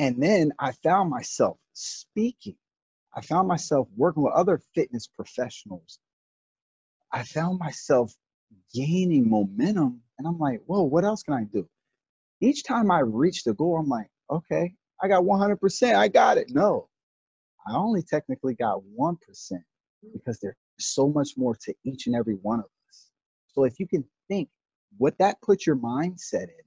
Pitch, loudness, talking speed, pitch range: 160 Hz, -25 LUFS, 160 wpm, 130-195 Hz